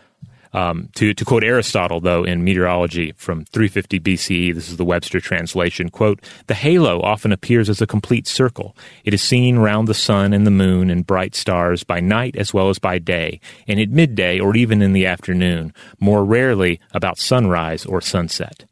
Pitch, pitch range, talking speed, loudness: 95 Hz, 90-105 Hz, 185 wpm, -17 LUFS